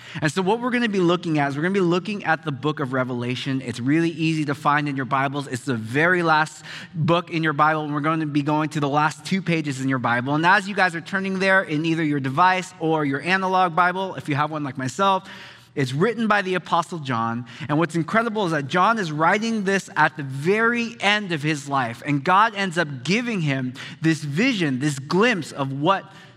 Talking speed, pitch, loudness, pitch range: 240 wpm, 160 Hz, -22 LUFS, 145-185 Hz